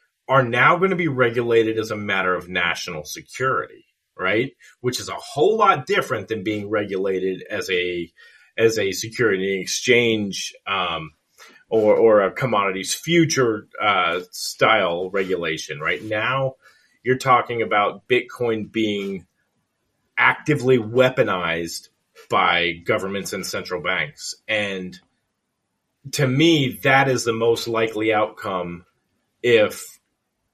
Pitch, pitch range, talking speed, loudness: 110 Hz, 95-130 Hz, 120 wpm, -20 LUFS